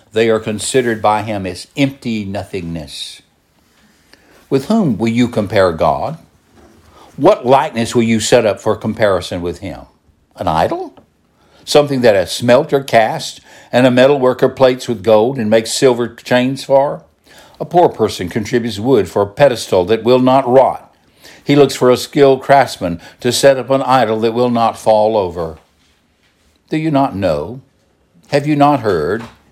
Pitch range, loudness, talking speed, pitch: 105-135 Hz, -14 LUFS, 165 wpm, 115 Hz